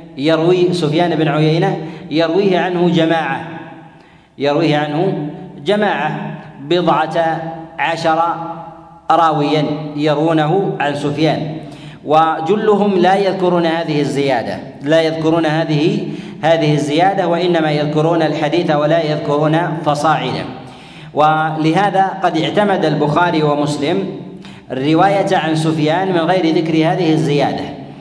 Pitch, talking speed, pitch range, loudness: 160 Hz, 95 wpm, 155-175 Hz, -15 LUFS